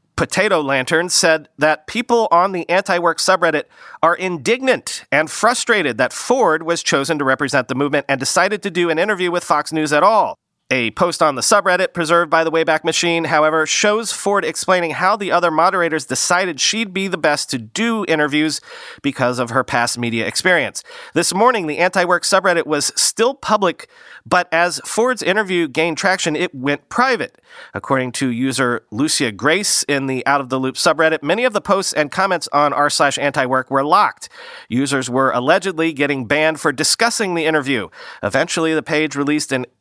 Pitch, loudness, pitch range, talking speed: 160 Hz, -16 LUFS, 145-180 Hz, 180 wpm